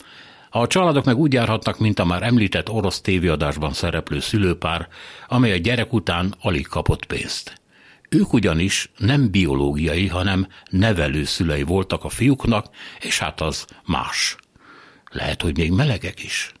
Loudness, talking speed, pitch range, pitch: -20 LUFS, 140 wpm, 85-110 Hz, 95 Hz